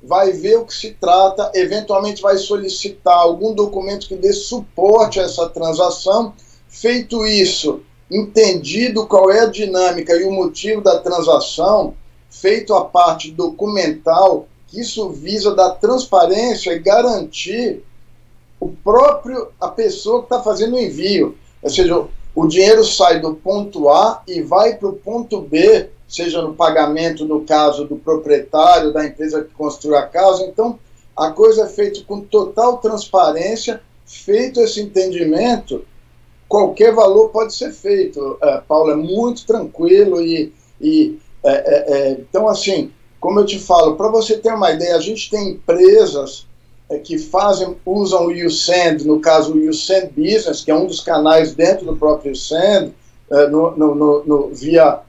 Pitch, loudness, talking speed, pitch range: 195 Hz, -14 LUFS, 155 wpm, 165-225 Hz